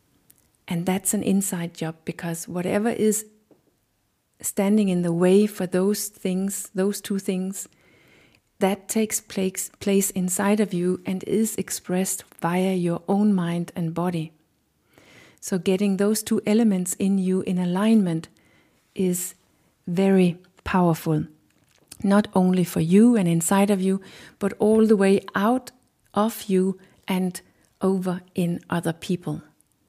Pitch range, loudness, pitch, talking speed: 180-205 Hz, -23 LUFS, 190 Hz, 130 wpm